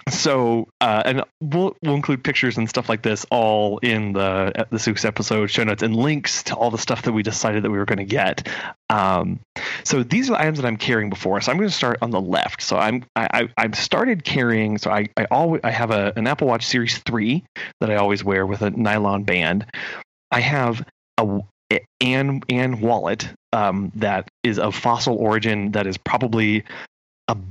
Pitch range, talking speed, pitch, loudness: 105-125 Hz, 205 wpm, 115 Hz, -21 LUFS